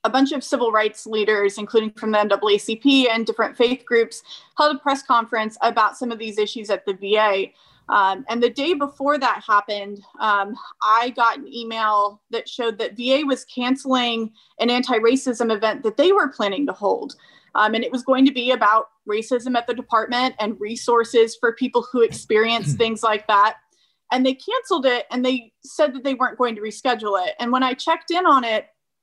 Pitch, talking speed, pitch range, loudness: 235 Hz, 200 wpm, 215-260 Hz, -20 LUFS